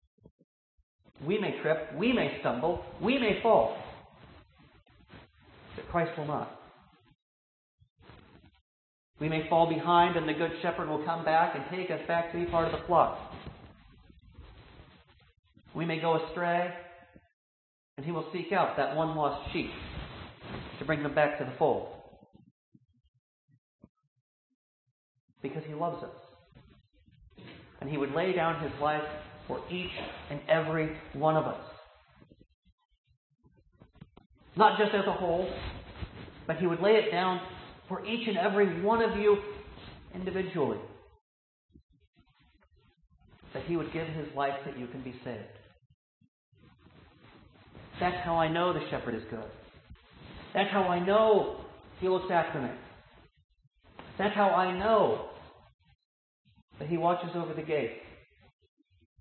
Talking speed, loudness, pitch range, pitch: 130 wpm, -30 LUFS, 125-180 Hz, 160 Hz